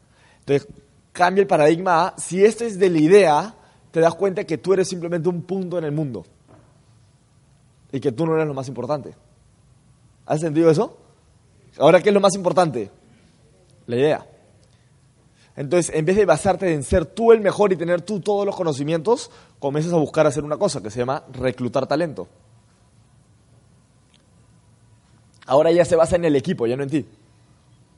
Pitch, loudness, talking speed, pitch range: 150 Hz, -20 LUFS, 170 wpm, 130-180 Hz